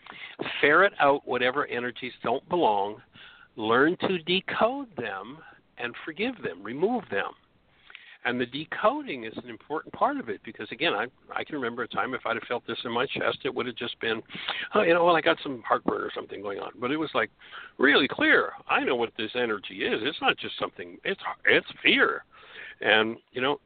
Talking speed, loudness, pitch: 205 wpm, -27 LUFS, 195 Hz